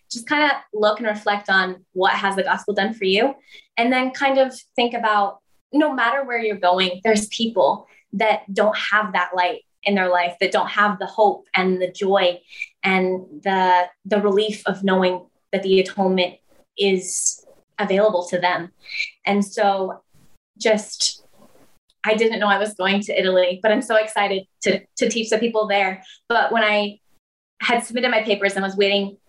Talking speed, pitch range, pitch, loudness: 180 wpm, 190-220 Hz, 205 Hz, -20 LUFS